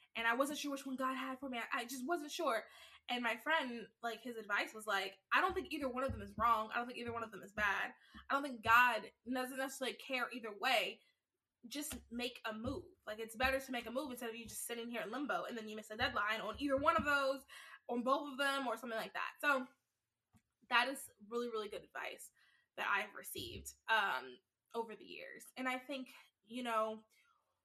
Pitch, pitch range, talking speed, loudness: 245 Hz, 225-275 Hz, 230 wpm, -39 LUFS